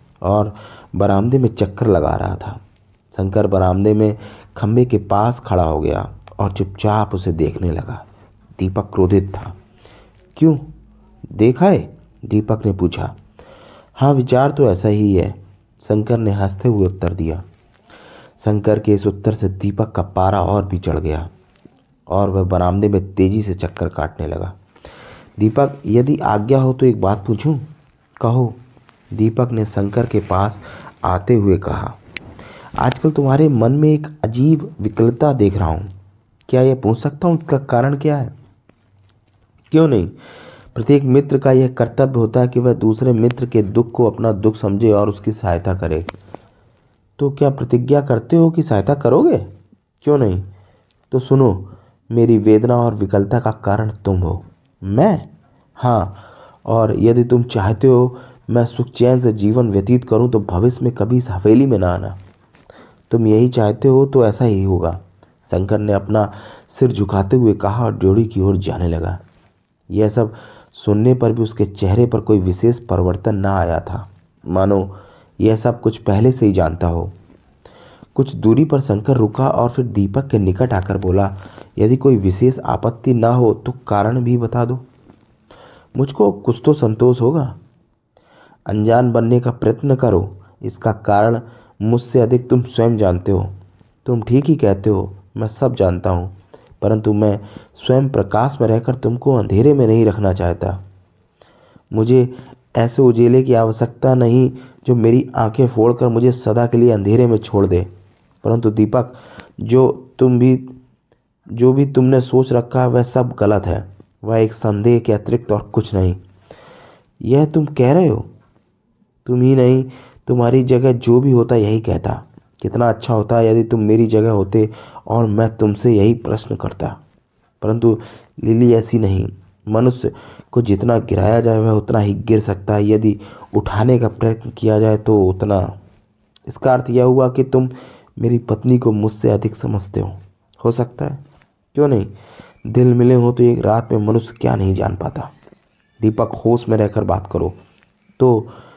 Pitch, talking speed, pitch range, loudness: 110 Hz, 160 wpm, 100-125 Hz, -16 LUFS